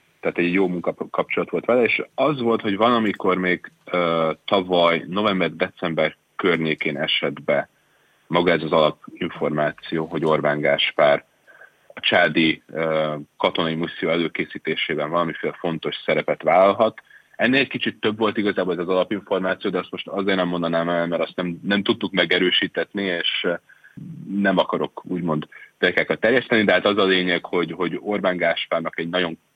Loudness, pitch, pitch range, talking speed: -21 LUFS, 85 Hz, 80-95 Hz, 150 wpm